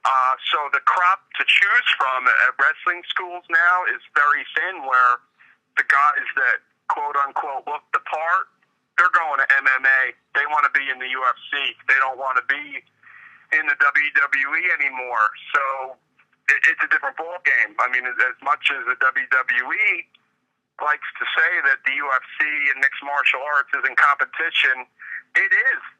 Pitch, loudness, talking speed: 145 Hz, -19 LUFS, 170 wpm